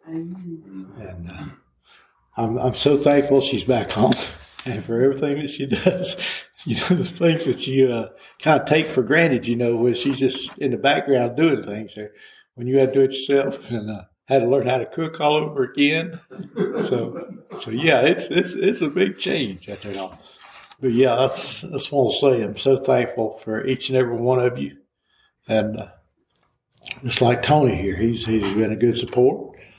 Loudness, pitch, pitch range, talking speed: -20 LUFS, 130 Hz, 115-140 Hz, 195 wpm